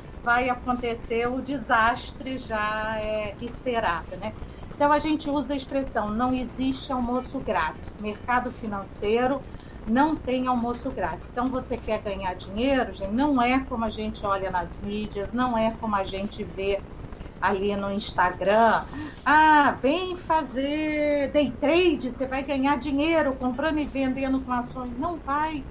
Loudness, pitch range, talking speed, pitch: -26 LUFS, 215-280 Hz, 145 wpm, 250 Hz